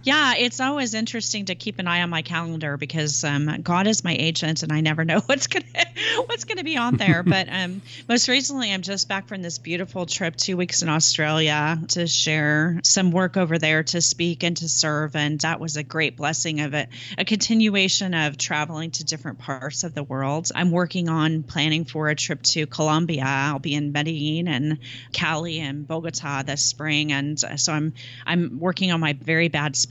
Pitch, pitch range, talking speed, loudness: 160 Hz, 150-180 Hz, 200 wpm, -22 LUFS